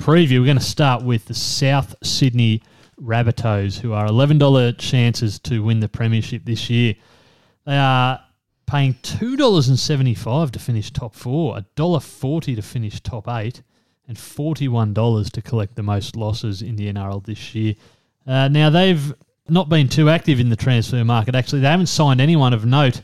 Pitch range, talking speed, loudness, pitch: 115-140 Hz, 165 wpm, -18 LUFS, 120 Hz